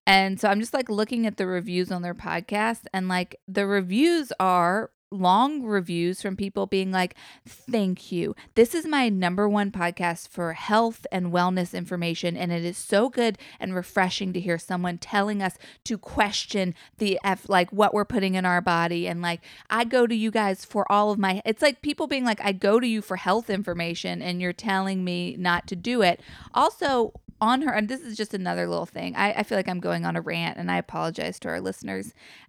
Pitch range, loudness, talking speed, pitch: 180-215 Hz, -25 LUFS, 210 wpm, 195 Hz